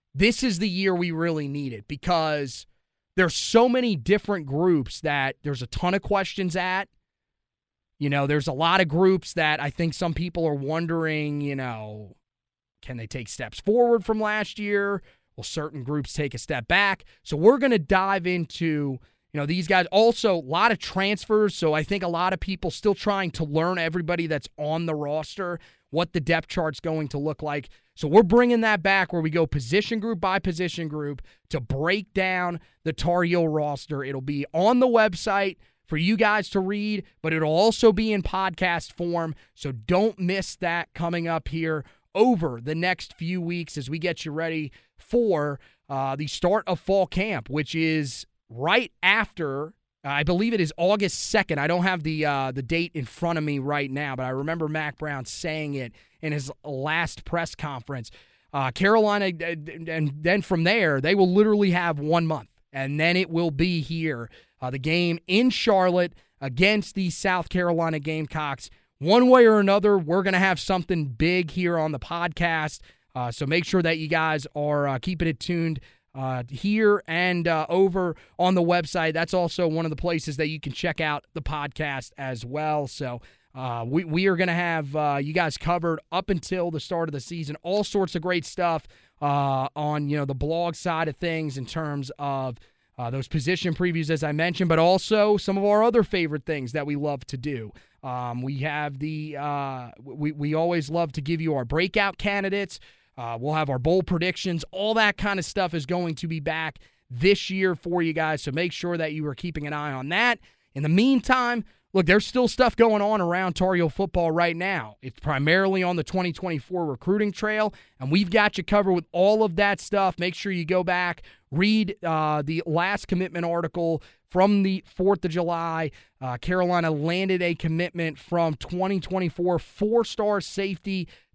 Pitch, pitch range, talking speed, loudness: 170 Hz, 150-190 Hz, 190 wpm, -24 LUFS